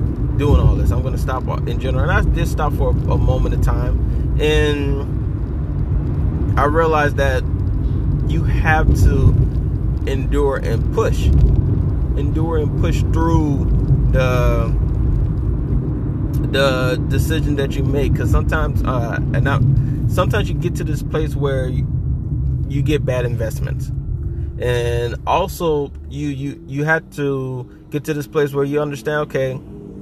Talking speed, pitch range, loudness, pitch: 140 wpm, 120-145 Hz, -18 LUFS, 135 Hz